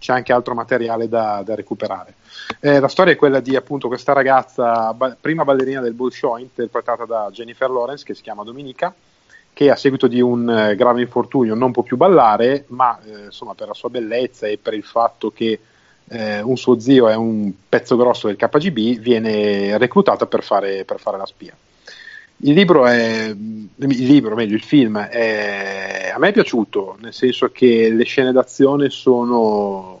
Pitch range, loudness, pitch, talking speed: 110-130 Hz, -16 LUFS, 120 Hz, 180 wpm